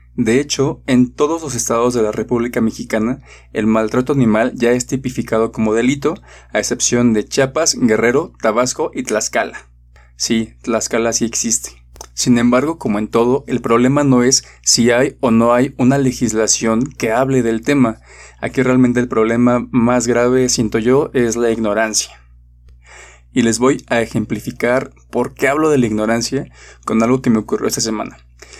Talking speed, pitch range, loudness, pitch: 165 wpm, 110-125 Hz, -15 LUFS, 120 Hz